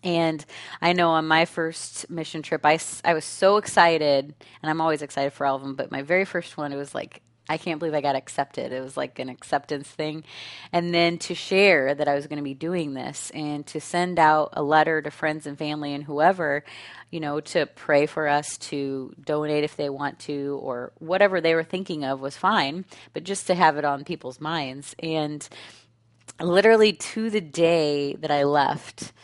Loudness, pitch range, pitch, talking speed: -24 LUFS, 145-170 Hz, 155 Hz, 205 wpm